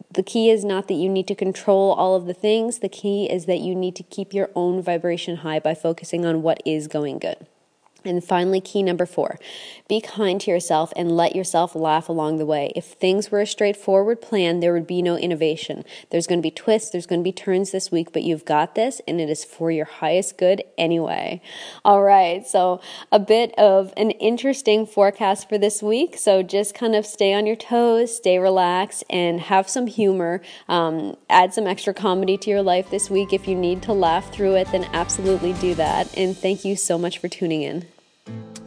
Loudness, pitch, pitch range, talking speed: -21 LUFS, 185 Hz, 170-200 Hz, 215 wpm